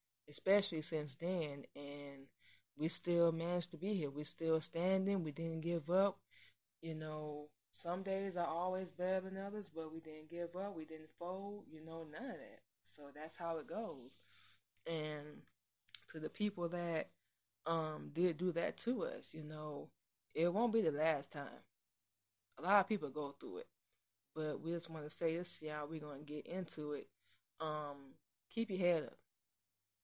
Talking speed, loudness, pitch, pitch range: 180 wpm, -41 LUFS, 160 Hz, 145-175 Hz